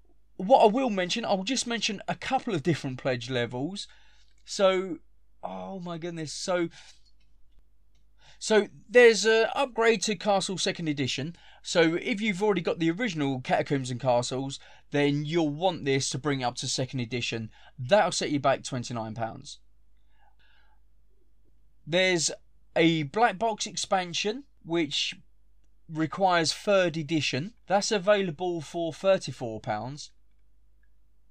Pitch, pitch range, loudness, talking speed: 165 Hz, 135-200 Hz, -27 LUFS, 125 wpm